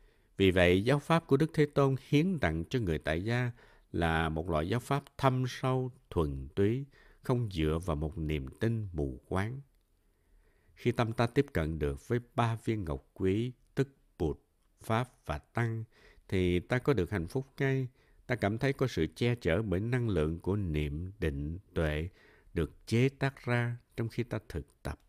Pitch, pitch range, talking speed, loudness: 105 Hz, 80-125 Hz, 185 wpm, -32 LUFS